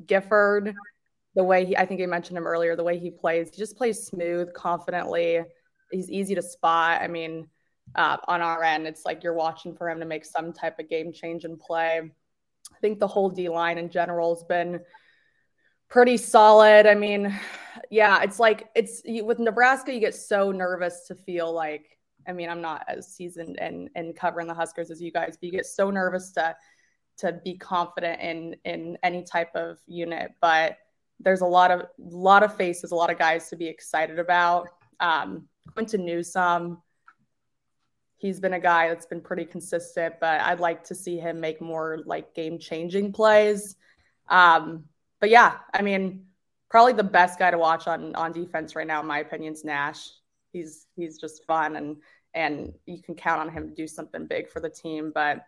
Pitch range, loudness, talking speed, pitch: 165-190 Hz, -24 LUFS, 195 wpm, 175 Hz